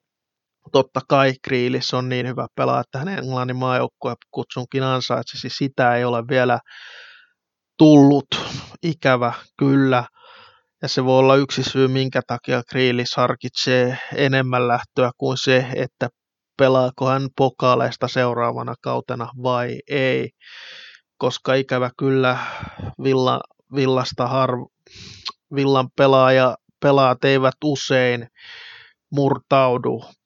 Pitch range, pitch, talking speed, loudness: 125-135 Hz, 130 Hz, 110 wpm, -19 LUFS